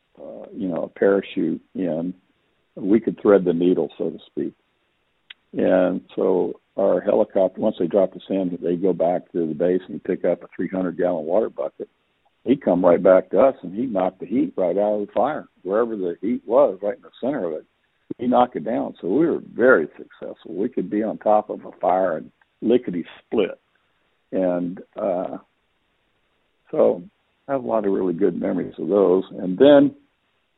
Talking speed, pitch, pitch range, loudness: 190 wpm, 100 Hz, 90-110 Hz, -21 LUFS